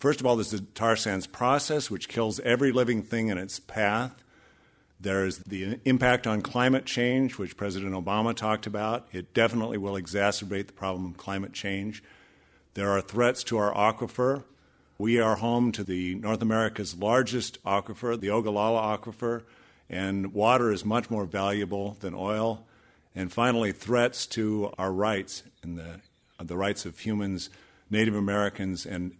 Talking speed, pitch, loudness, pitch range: 160 wpm, 105 Hz, -28 LUFS, 95-115 Hz